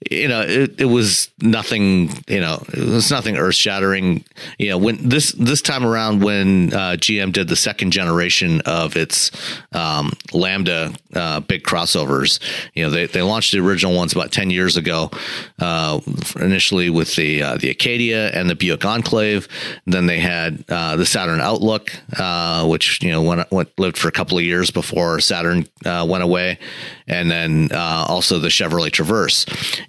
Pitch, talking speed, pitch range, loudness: 90 Hz, 185 wpm, 85-105 Hz, -17 LUFS